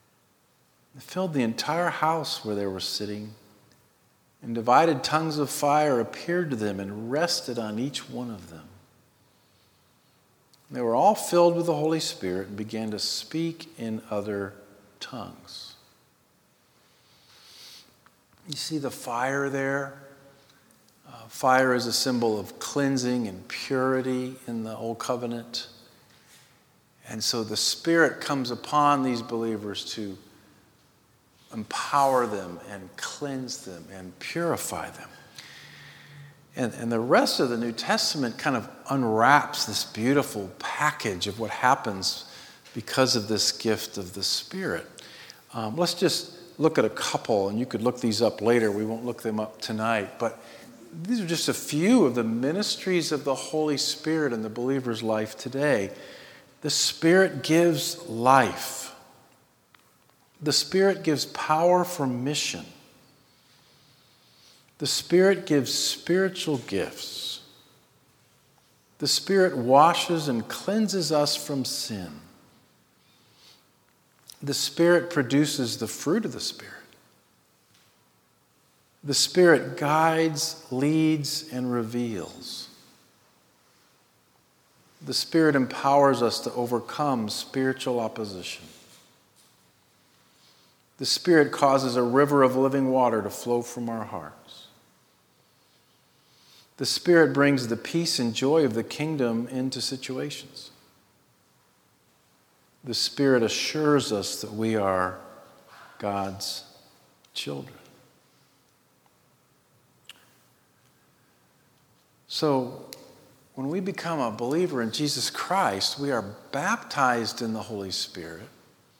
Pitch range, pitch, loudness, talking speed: 110-150 Hz, 130 Hz, -25 LUFS, 115 wpm